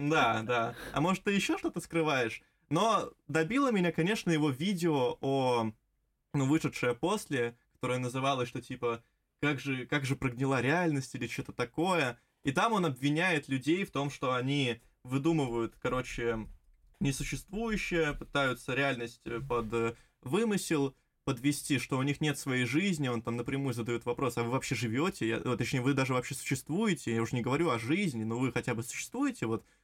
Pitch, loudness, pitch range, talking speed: 135 Hz, -32 LUFS, 120-160 Hz, 160 wpm